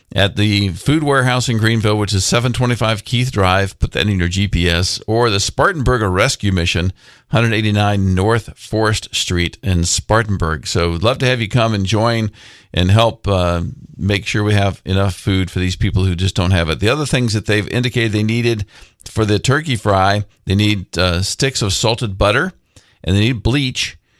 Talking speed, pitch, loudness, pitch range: 190 wpm, 105 Hz, -16 LUFS, 95-115 Hz